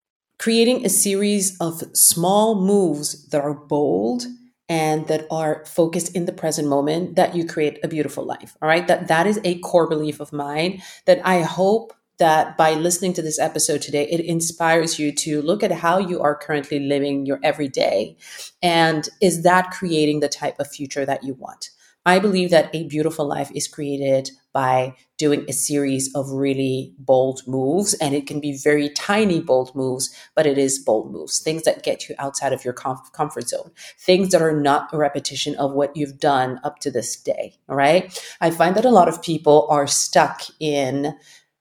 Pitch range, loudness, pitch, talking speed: 140-175 Hz, -20 LUFS, 155 Hz, 190 wpm